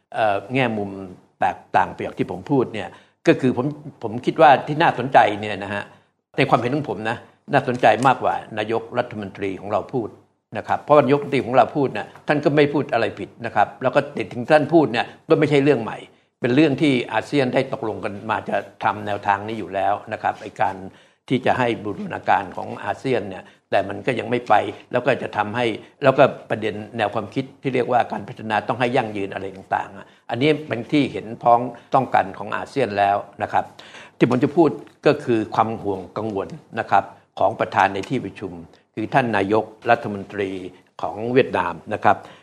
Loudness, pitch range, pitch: -21 LUFS, 100-135 Hz, 115 Hz